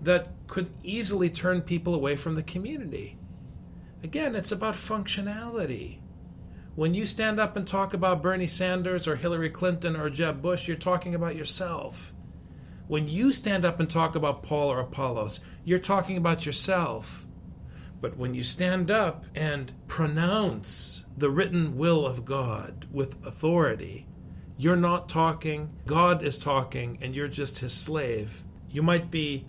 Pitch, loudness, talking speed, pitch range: 165 Hz, -28 LUFS, 150 wpm, 140-180 Hz